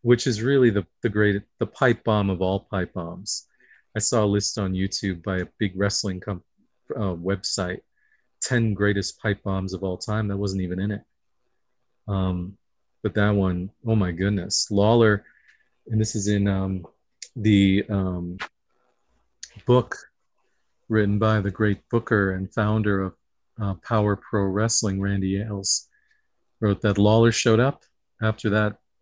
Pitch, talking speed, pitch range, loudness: 100 Hz, 155 wpm, 95-110 Hz, -24 LUFS